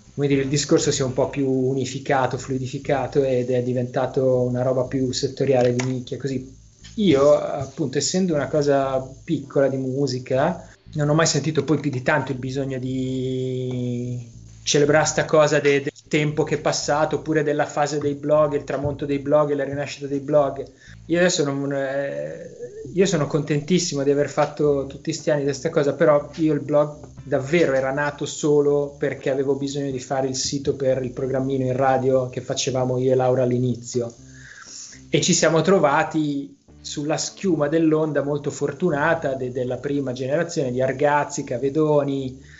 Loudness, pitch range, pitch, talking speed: -22 LUFS, 130-150 Hz, 140 Hz, 170 wpm